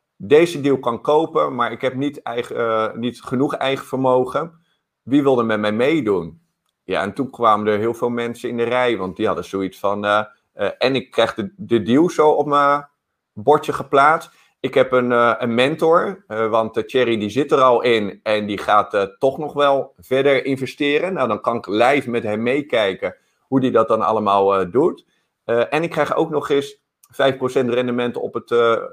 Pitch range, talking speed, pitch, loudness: 110-140 Hz, 205 wpm, 125 Hz, -19 LUFS